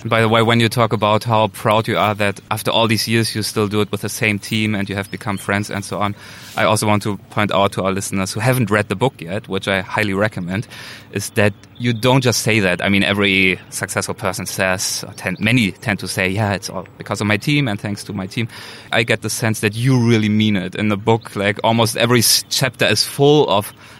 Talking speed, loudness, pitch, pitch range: 255 wpm, -17 LUFS, 105 Hz, 100-115 Hz